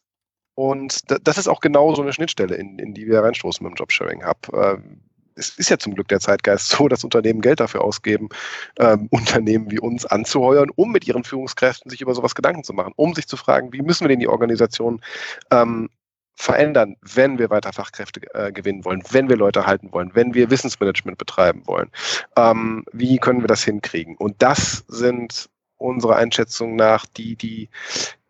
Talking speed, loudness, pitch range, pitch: 180 wpm, -19 LUFS, 105-130 Hz, 115 Hz